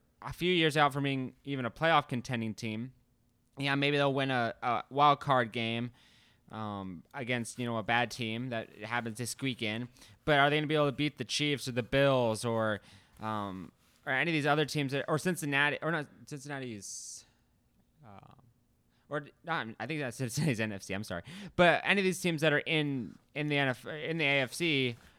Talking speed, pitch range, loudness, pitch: 200 wpm, 115-145 Hz, -31 LUFS, 130 Hz